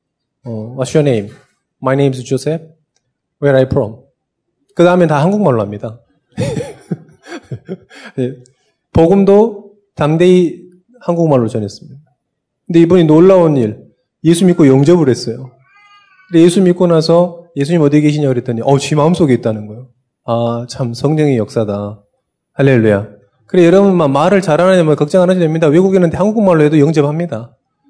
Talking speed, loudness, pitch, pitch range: 365 characters per minute, -12 LUFS, 150 Hz, 125-175 Hz